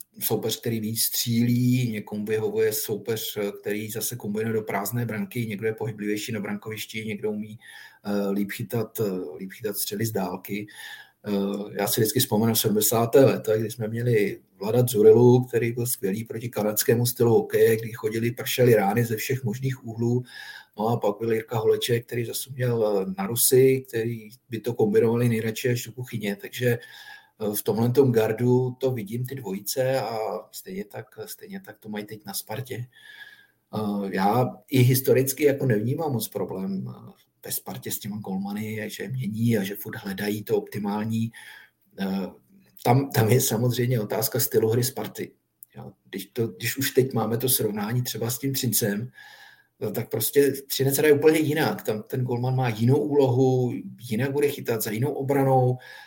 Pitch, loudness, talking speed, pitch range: 115 Hz, -24 LUFS, 165 wpm, 105-130 Hz